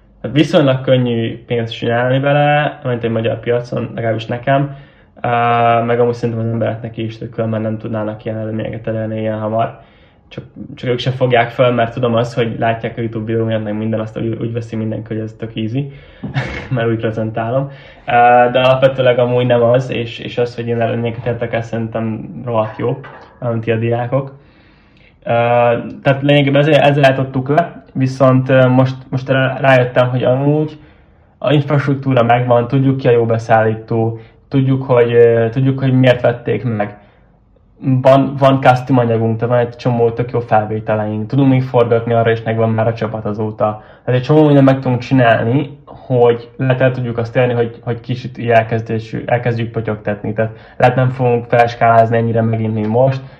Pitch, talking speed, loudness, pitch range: 120 Hz, 170 wpm, -15 LUFS, 115-130 Hz